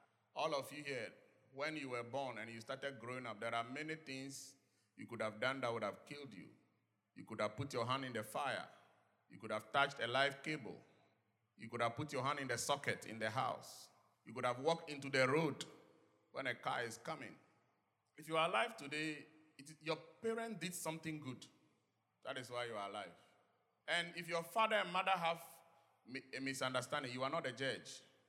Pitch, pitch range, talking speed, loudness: 135 Hz, 125-160 Hz, 205 wpm, -42 LUFS